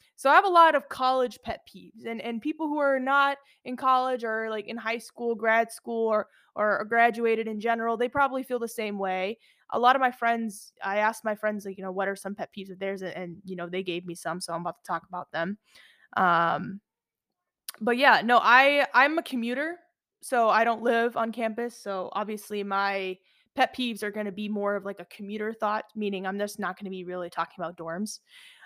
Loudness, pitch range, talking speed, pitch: -26 LUFS, 195-245 Hz, 220 wpm, 220 Hz